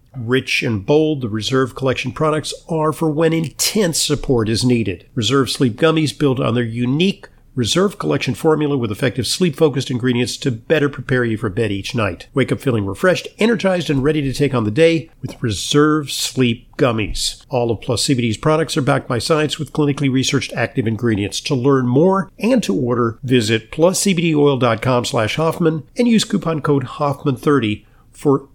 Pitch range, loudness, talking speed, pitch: 120-155 Hz, -17 LUFS, 170 wpm, 135 Hz